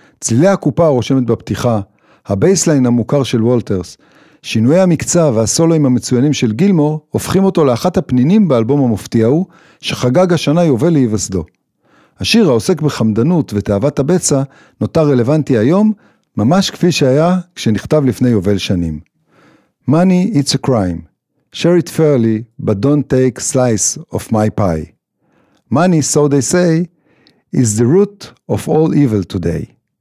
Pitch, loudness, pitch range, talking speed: 140 Hz, -13 LUFS, 115-165 Hz, 130 wpm